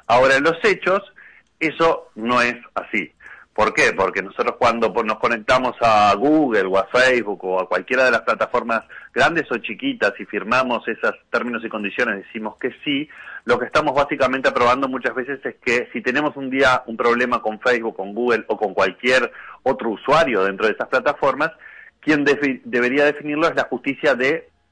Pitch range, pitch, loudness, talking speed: 120-160 Hz, 135 Hz, -19 LUFS, 180 wpm